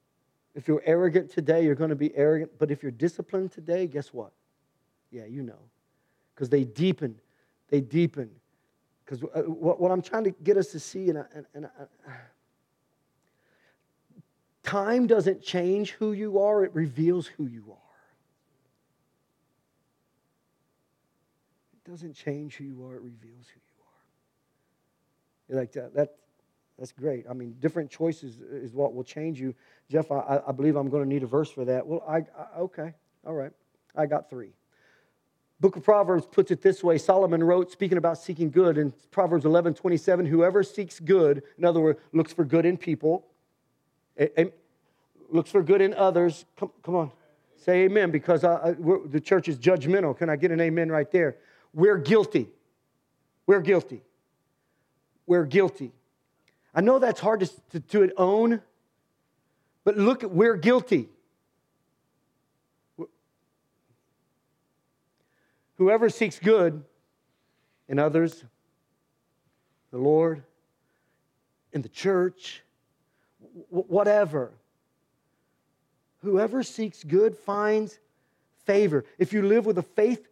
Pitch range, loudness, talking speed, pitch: 145-190 Hz, -25 LUFS, 145 wpm, 165 Hz